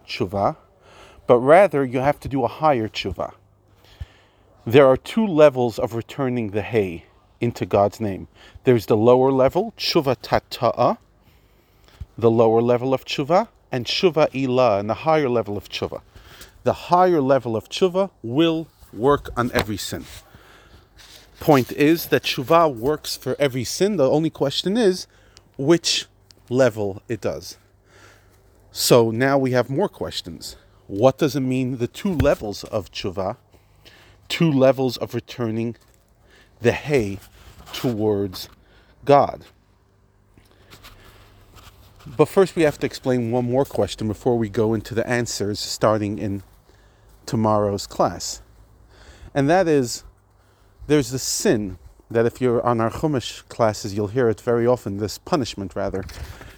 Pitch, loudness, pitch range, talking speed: 115 Hz, -21 LUFS, 100-130 Hz, 140 wpm